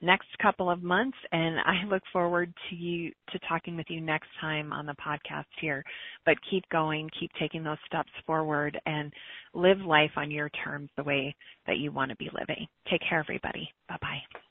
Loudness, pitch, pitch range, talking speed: -30 LUFS, 165 Hz, 150-175 Hz, 195 wpm